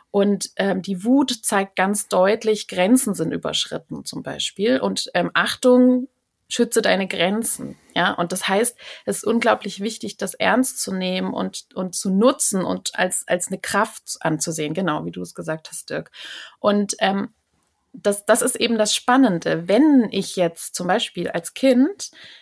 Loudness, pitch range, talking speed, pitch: -20 LUFS, 185-240 Hz, 165 wpm, 200 Hz